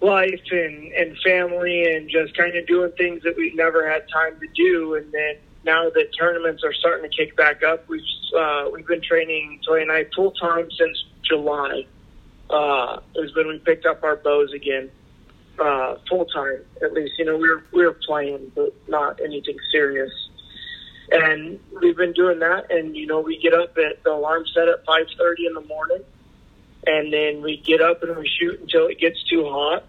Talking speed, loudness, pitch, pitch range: 195 wpm, -20 LUFS, 165 Hz, 155-180 Hz